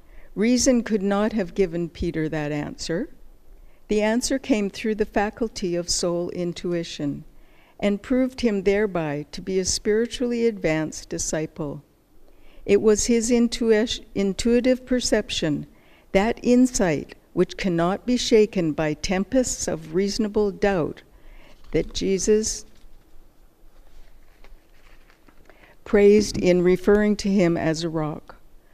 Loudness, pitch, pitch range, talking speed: -23 LUFS, 205 Hz, 175-230 Hz, 115 wpm